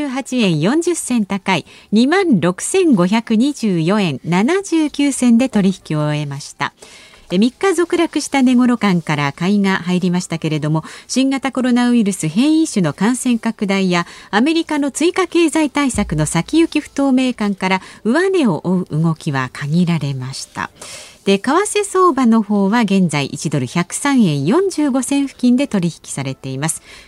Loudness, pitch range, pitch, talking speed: -16 LUFS, 175-280 Hz, 215 Hz, 255 characters per minute